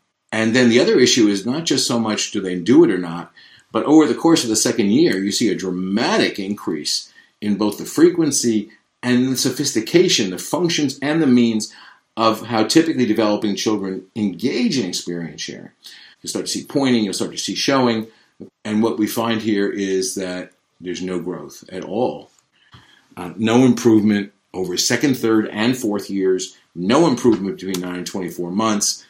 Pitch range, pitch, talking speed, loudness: 95-120 Hz, 110 Hz, 180 wpm, -18 LUFS